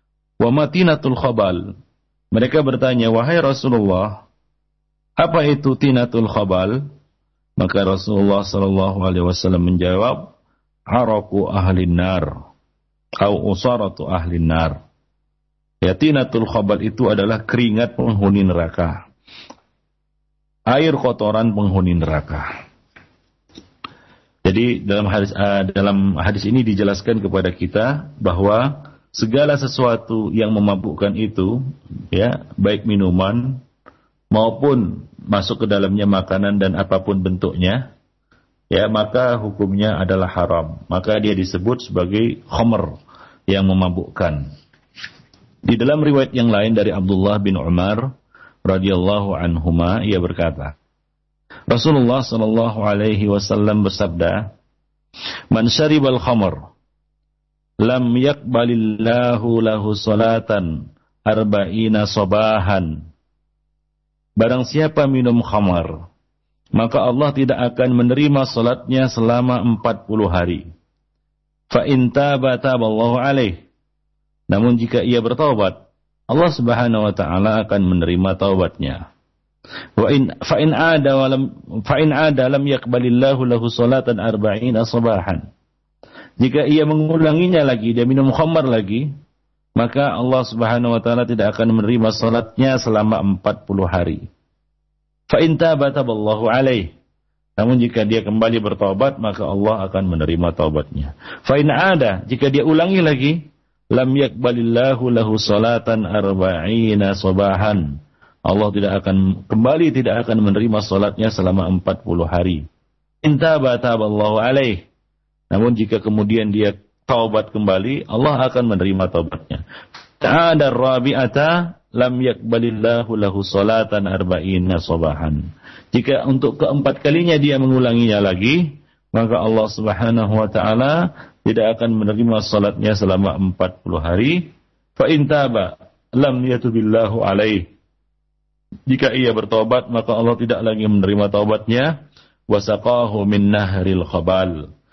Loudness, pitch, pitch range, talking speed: -17 LUFS, 110 Hz, 95-125 Hz, 110 wpm